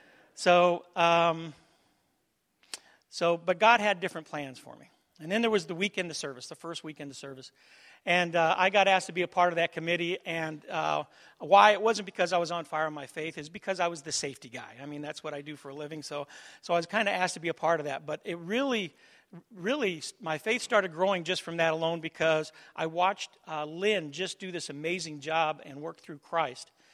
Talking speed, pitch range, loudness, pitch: 230 wpm, 155-185 Hz, -29 LUFS, 170 Hz